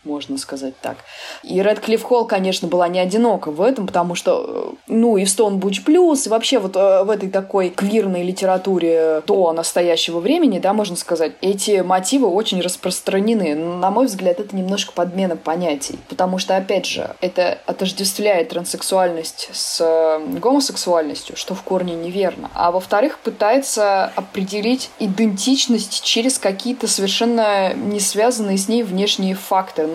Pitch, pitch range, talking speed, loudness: 195 Hz, 180-225 Hz, 145 wpm, -18 LUFS